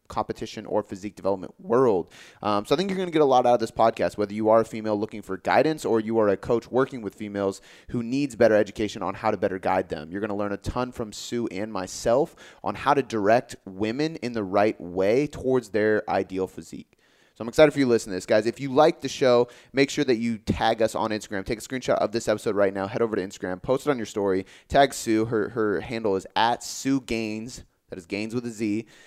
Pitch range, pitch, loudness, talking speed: 105-125 Hz, 110 Hz, -25 LUFS, 255 wpm